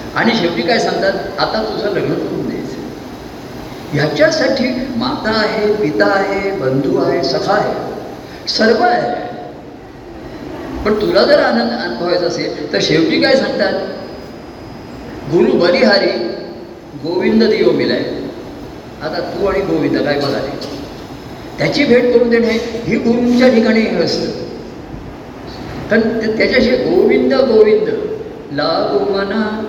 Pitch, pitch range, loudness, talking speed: 230 Hz, 215-270 Hz, -14 LUFS, 110 wpm